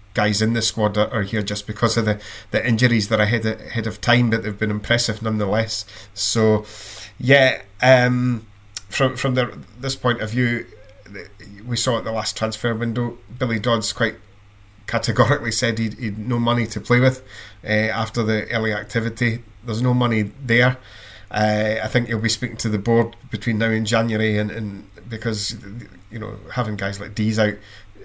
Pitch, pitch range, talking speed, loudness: 110 Hz, 105-120 Hz, 180 wpm, -20 LUFS